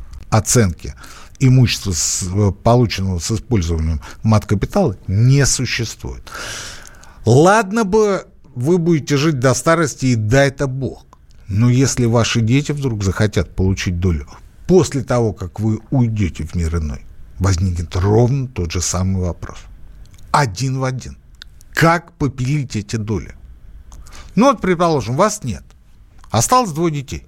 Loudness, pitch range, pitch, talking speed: -17 LUFS, 90-140 Hz, 115 Hz, 125 wpm